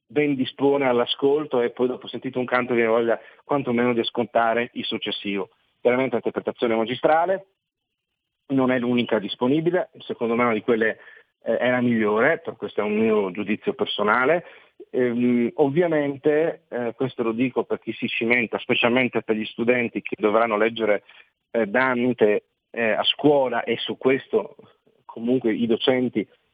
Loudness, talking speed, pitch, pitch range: -23 LUFS, 150 wpm, 120 Hz, 115-130 Hz